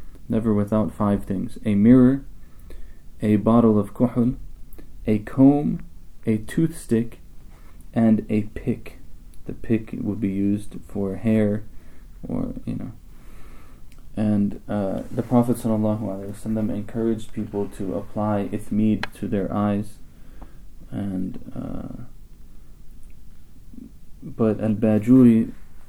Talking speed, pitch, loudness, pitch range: 110 wpm, 105 Hz, -22 LUFS, 90-110 Hz